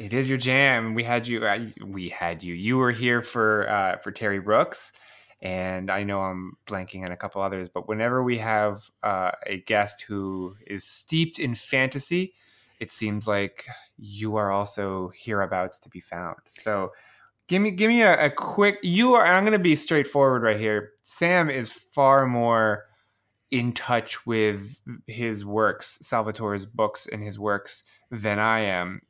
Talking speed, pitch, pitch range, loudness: 170 wpm, 110 Hz, 100-130 Hz, -24 LUFS